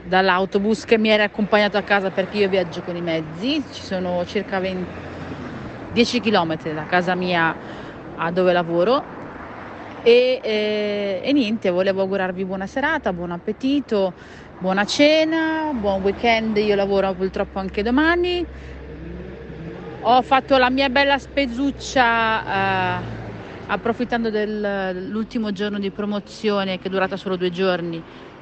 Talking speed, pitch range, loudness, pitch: 135 wpm, 185-235 Hz, -20 LUFS, 205 Hz